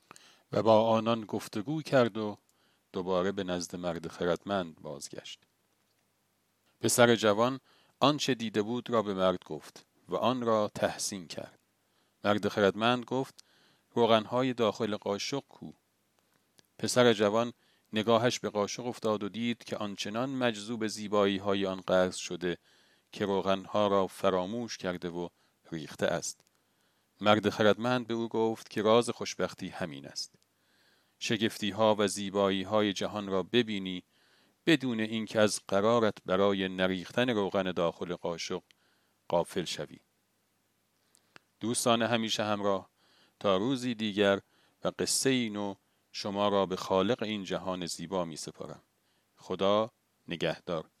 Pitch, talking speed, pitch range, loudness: 105 Hz, 125 wpm, 95-115 Hz, -30 LUFS